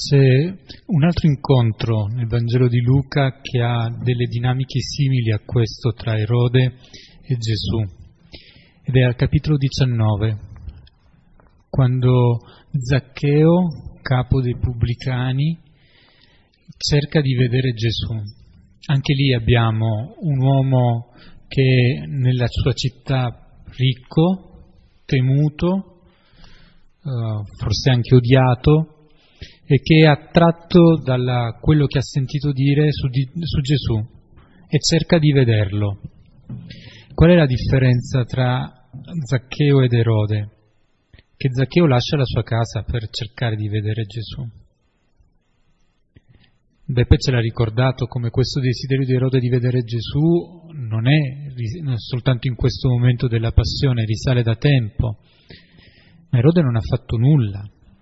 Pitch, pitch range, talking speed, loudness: 125 Hz, 115-140 Hz, 120 wpm, -18 LUFS